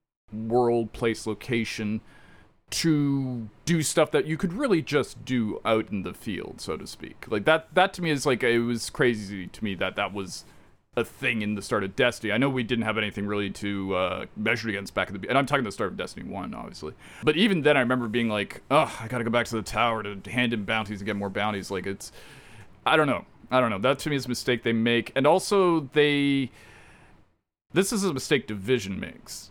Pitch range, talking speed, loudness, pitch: 105-135 Hz, 230 wpm, -26 LUFS, 115 Hz